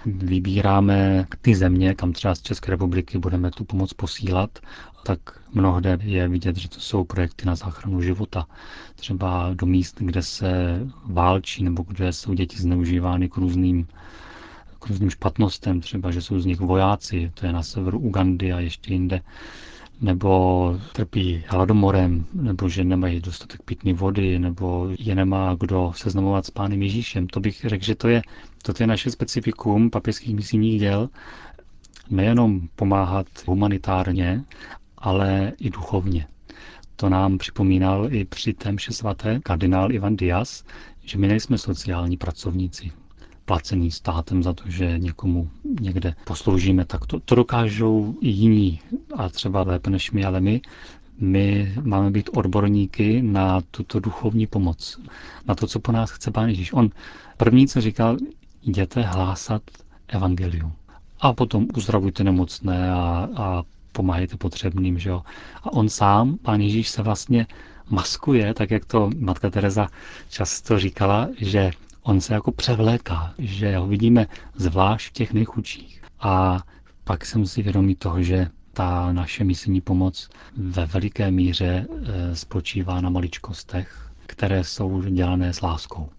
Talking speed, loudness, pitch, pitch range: 145 wpm, -22 LUFS, 95 Hz, 90-105 Hz